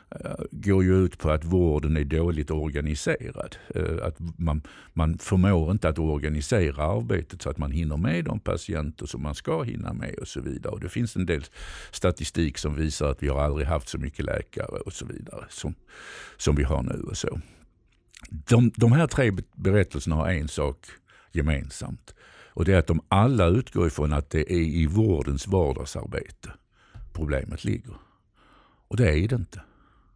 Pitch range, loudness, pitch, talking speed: 75-95 Hz, -26 LUFS, 85 Hz, 175 wpm